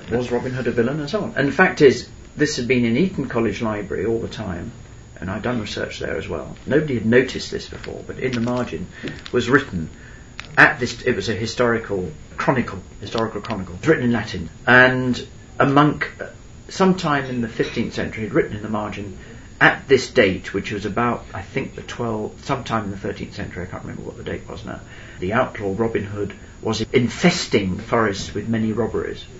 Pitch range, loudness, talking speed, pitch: 105-125 Hz, -21 LUFS, 205 wpm, 115 Hz